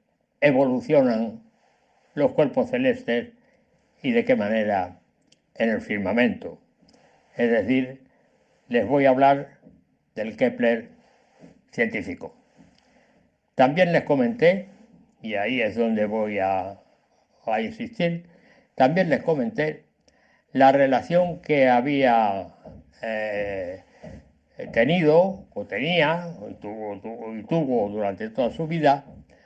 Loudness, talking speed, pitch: -23 LUFS, 100 wpm, 145 Hz